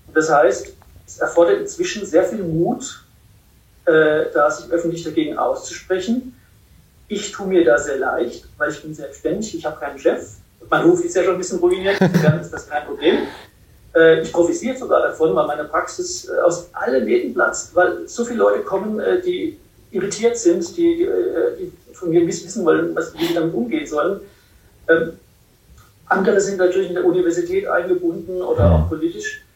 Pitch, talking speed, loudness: 190 Hz, 180 wpm, -19 LUFS